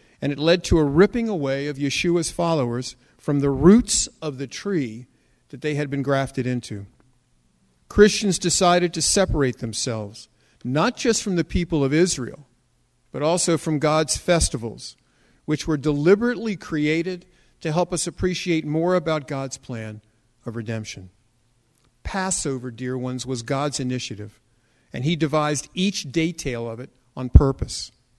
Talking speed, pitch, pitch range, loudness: 145 wpm, 140 Hz, 120-170 Hz, -22 LUFS